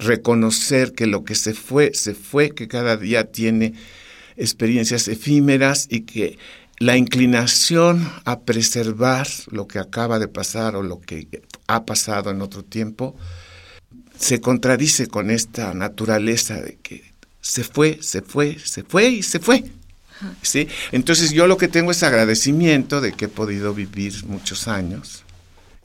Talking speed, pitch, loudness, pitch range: 150 wpm, 115 Hz, -19 LUFS, 105-135 Hz